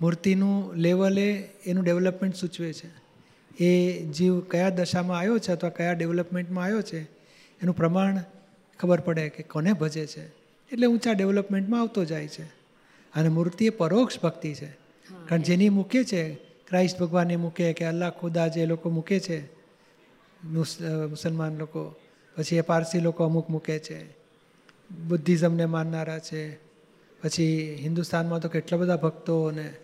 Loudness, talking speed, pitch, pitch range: -26 LUFS, 140 wpm, 170 Hz, 160-180 Hz